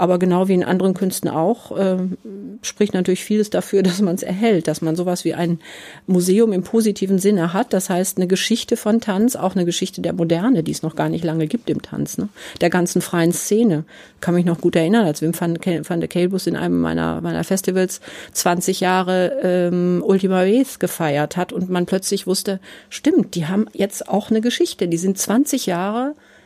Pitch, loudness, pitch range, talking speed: 185 Hz, -19 LUFS, 175-200 Hz, 200 wpm